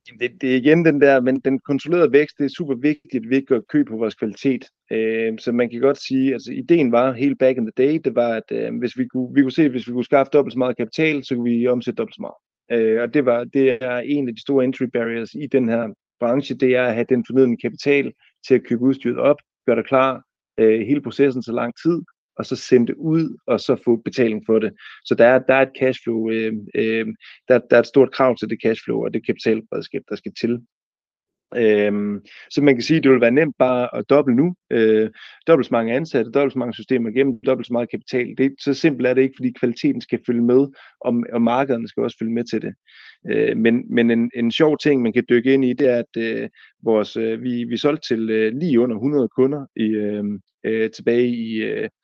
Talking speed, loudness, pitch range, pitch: 245 wpm, -19 LUFS, 115-135 Hz, 125 Hz